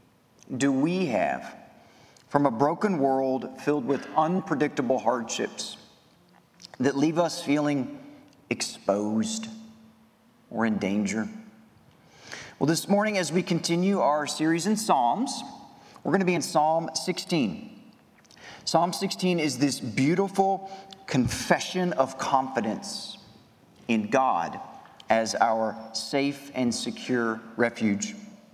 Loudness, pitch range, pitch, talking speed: -26 LUFS, 130-195 Hz, 155 Hz, 110 wpm